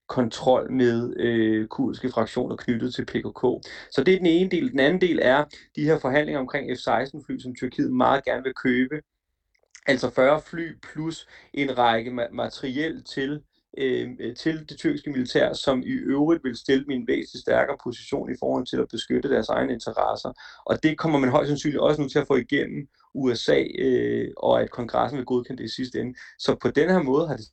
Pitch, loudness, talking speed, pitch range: 130 Hz, -24 LUFS, 195 wpm, 125-150 Hz